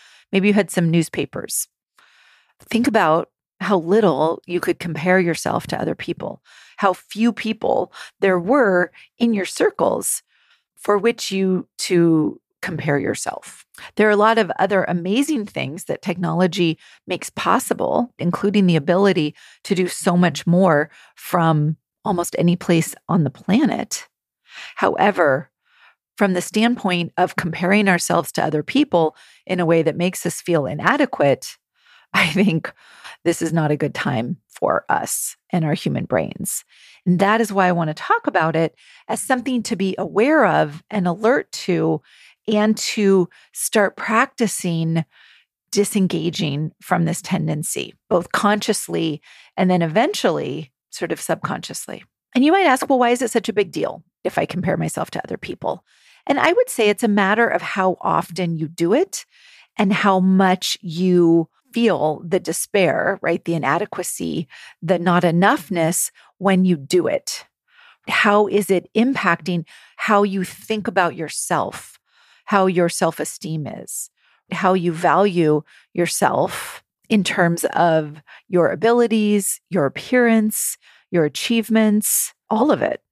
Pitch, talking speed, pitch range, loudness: 185 Hz, 145 wpm, 170-210 Hz, -19 LUFS